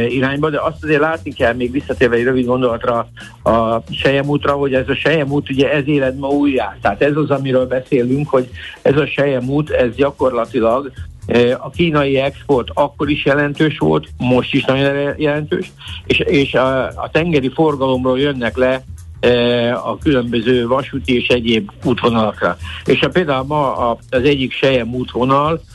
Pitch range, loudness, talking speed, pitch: 120-145 Hz, -16 LUFS, 155 wpm, 130 Hz